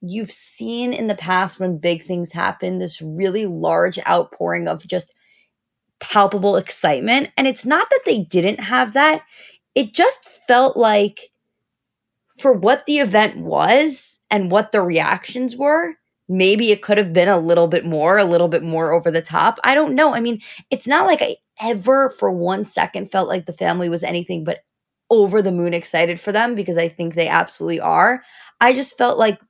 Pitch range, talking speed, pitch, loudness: 175-250 Hz, 185 wpm, 205 Hz, -17 LUFS